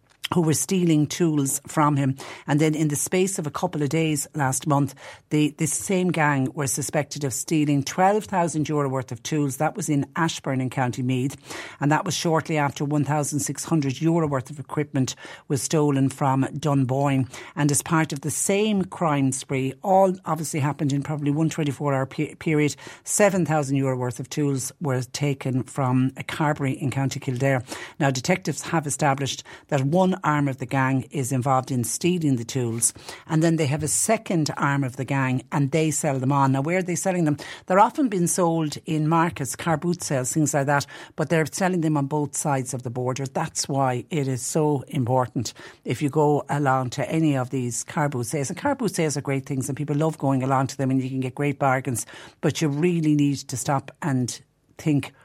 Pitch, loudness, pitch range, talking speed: 145 Hz, -24 LUFS, 135-160 Hz, 210 wpm